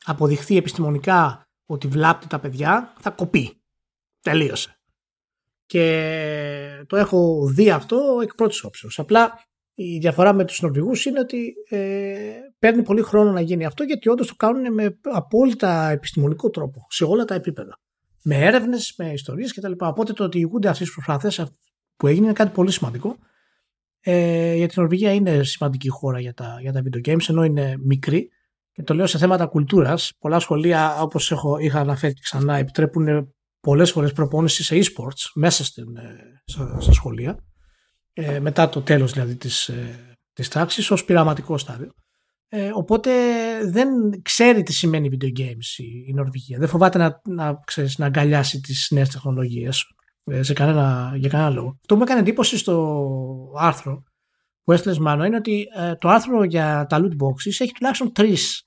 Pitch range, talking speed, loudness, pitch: 145-200 Hz, 160 wpm, -20 LUFS, 165 Hz